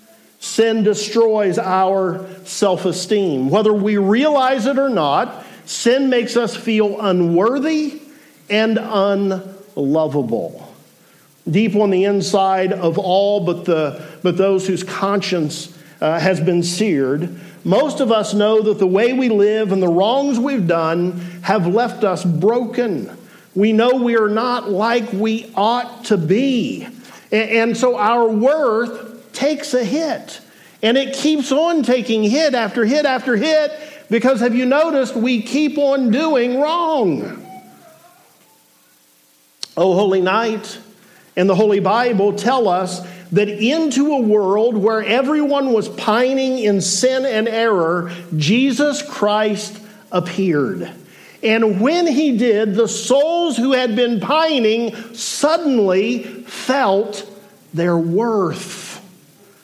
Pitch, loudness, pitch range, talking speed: 220 Hz, -17 LUFS, 190-250 Hz, 130 wpm